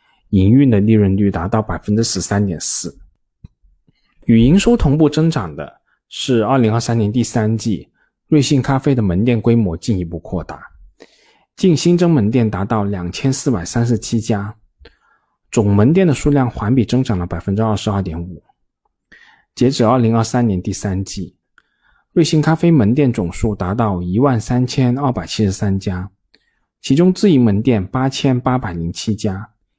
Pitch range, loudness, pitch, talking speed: 100-130 Hz, -16 LUFS, 110 Hz, 250 characters per minute